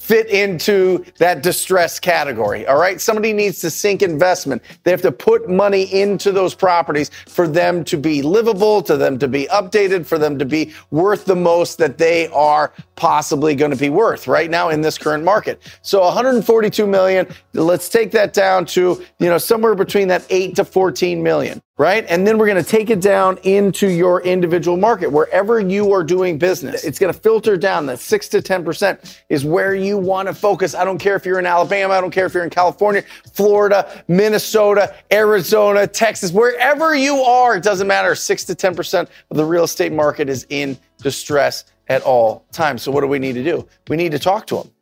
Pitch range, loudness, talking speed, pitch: 170-205 Hz, -16 LUFS, 205 wpm, 185 Hz